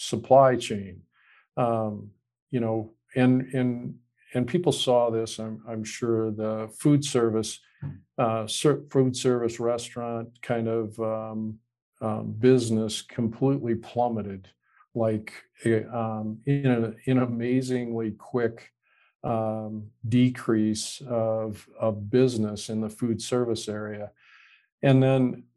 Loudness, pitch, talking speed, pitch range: -26 LUFS, 115 Hz, 110 wpm, 110-125 Hz